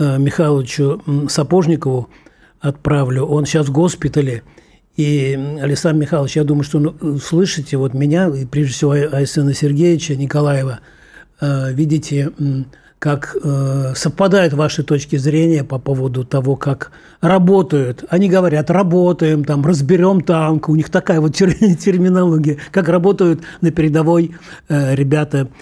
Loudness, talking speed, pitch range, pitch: -15 LUFS, 115 wpm, 140-170 Hz, 150 Hz